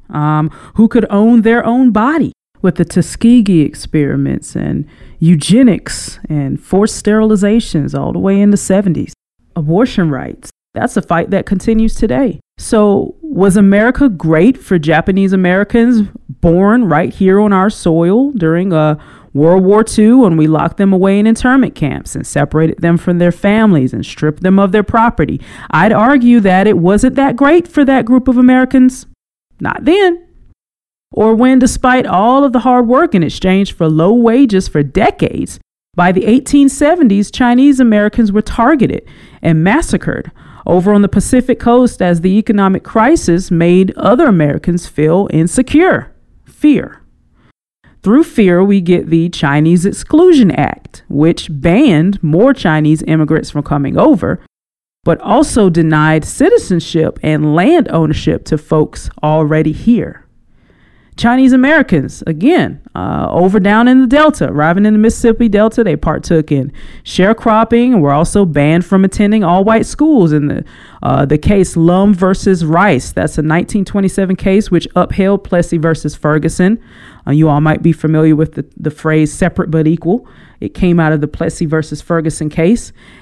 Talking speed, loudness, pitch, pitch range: 150 wpm, -11 LUFS, 195 Hz, 160-230 Hz